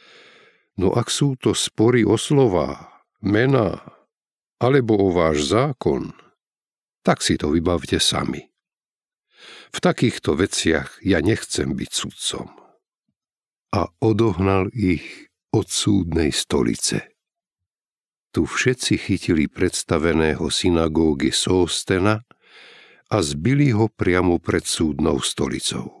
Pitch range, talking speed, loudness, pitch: 90-150 Hz, 100 wpm, -20 LUFS, 110 Hz